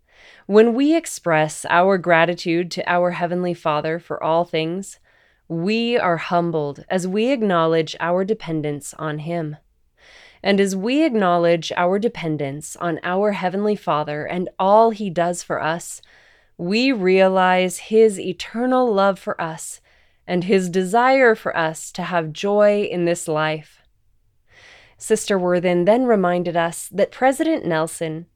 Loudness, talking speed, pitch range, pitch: -19 LUFS, 135 wpm, 165-205 Hz, 175 Hz